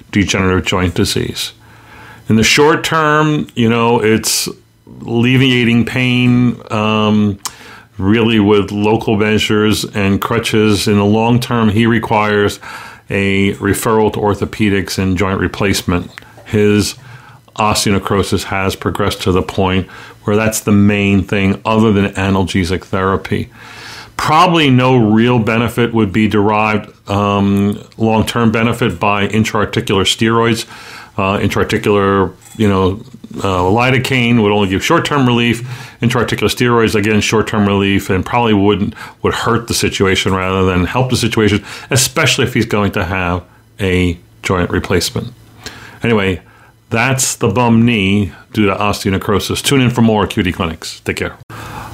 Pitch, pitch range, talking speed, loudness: 110 Hz, 100-115 Hz, 135 wpm, -13 LUFS